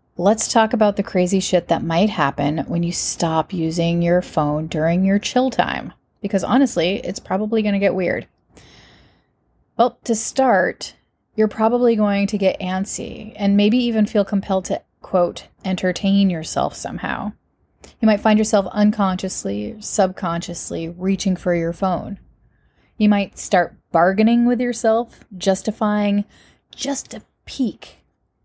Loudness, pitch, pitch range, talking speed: -19 LUFS, 195 Hz, 175-215 Hz, 140 wpm